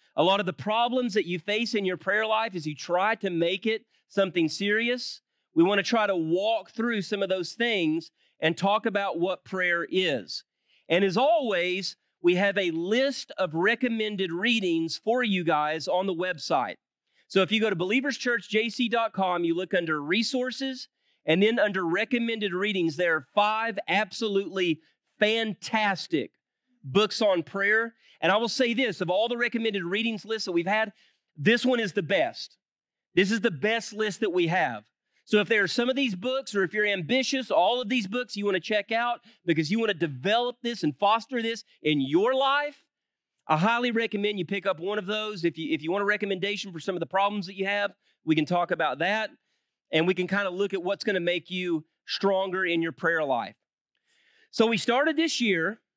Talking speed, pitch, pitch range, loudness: 200 wpm, 210 Hz, 185-235 Hz, -26 LUFS